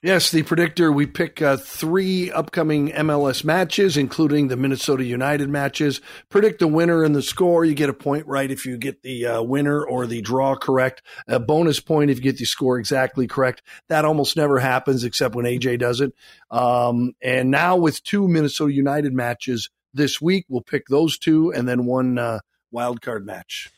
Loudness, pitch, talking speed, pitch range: -20 LUFS, 140 Hz, 190 wpm, 130-155 Hz